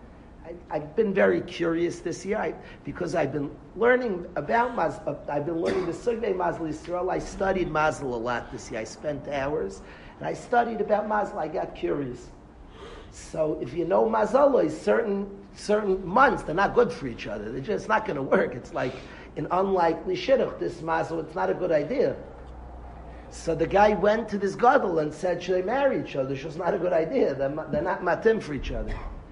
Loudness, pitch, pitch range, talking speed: -26 LUFS, 175 Hz, 150-210 Hz, 200 wpm